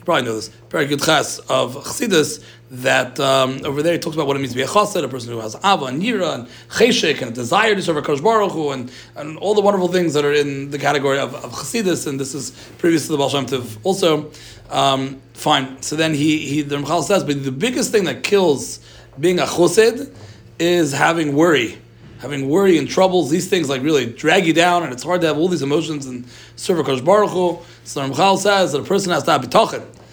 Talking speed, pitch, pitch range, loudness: 225 wpm, 150 Hz, 135-175 Hz, -18 LUFS